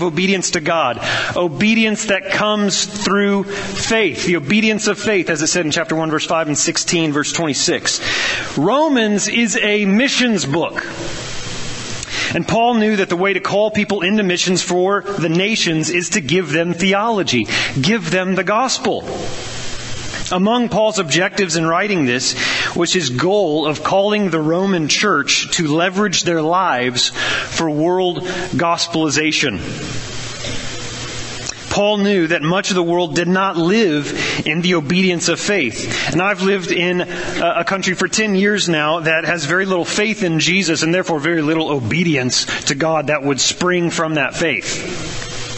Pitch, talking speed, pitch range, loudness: 175 Hz, 155 wpm, 155-195 Hz, -16 LUFS